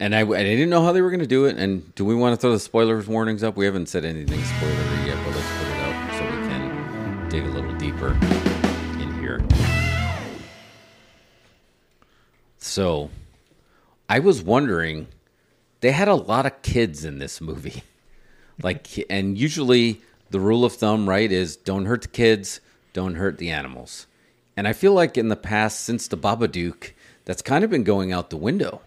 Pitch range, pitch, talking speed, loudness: 80-115 Hz, 100 Hz, 185 wpm, -22 LUFS